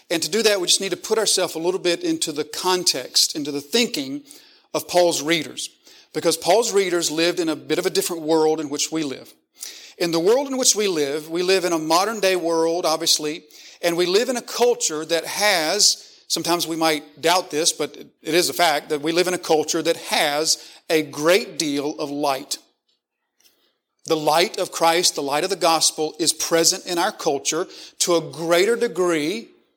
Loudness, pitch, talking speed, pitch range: -20 LUFS, 165 Hz, 205 wpm, 155-185 Hz